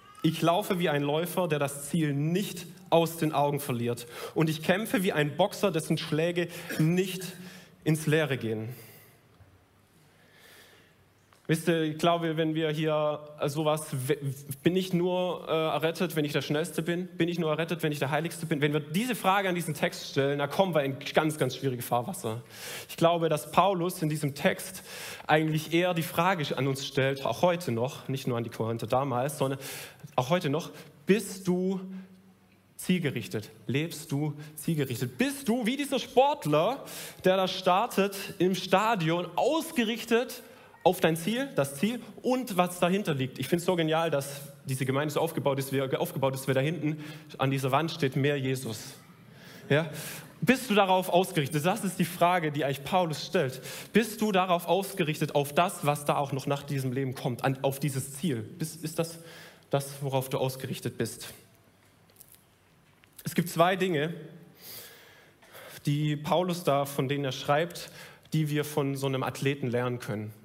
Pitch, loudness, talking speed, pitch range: 155 Hz, -29 LUFS, 170 wpm, 140-180 Hz